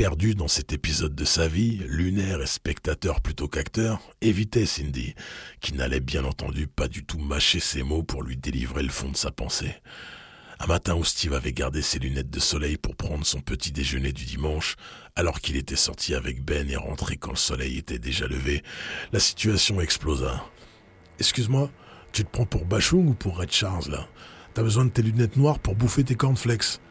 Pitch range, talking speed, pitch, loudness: 70-100 Hz, 195 wpm, 80 Hz, -25 LUFS